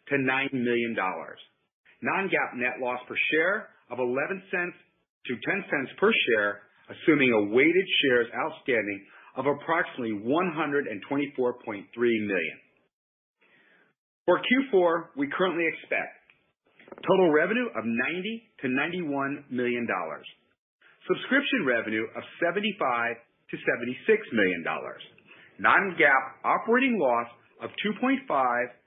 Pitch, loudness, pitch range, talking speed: 140 Hz, -26 LUFS, 120-185 Hz, 110 wpm